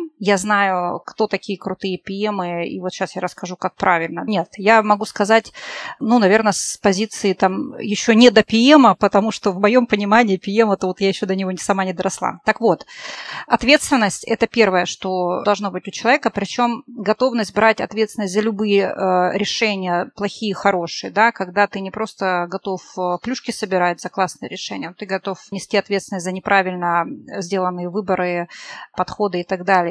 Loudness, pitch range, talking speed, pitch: -18 LUFS, 185-220 Hz, 170 wpm, 200 Hz